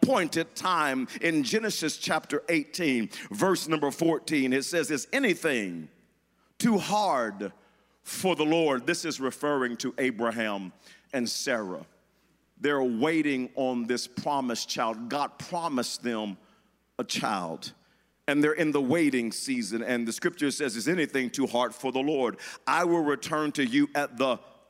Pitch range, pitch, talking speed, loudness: 125-165 Hz, 145 Hz, 145 wpm, -28 LUFS